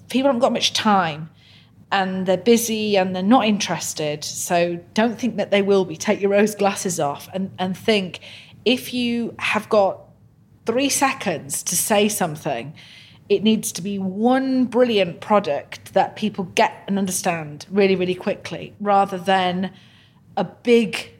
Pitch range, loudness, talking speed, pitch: 180-220 Hz, -20 LUFS, 155 wpm, 195 Hz